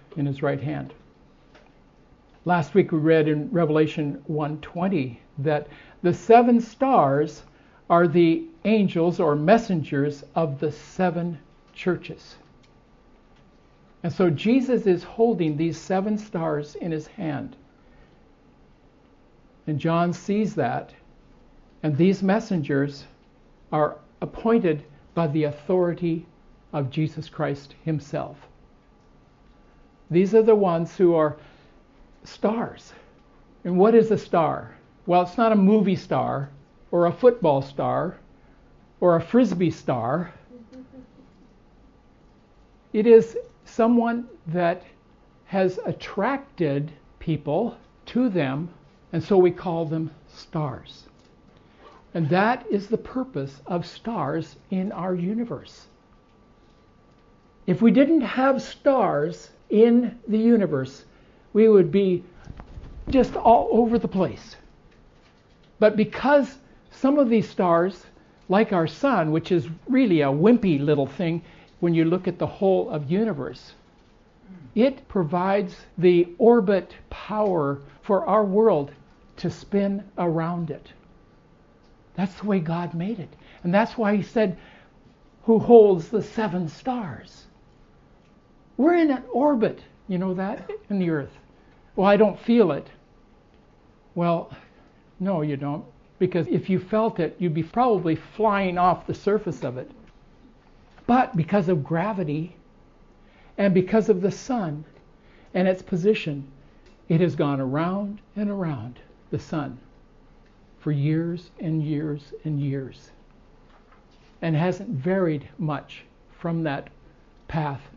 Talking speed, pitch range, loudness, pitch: 120 wpm, 155-215 Hz, -23 LUFS, 180 Hz